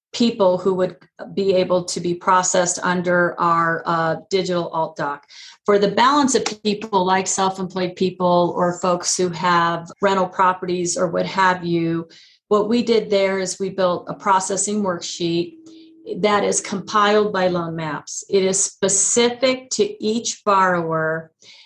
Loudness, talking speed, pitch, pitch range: -19 LUFS, 150 wpm, 185 Hz, 175-205 Hz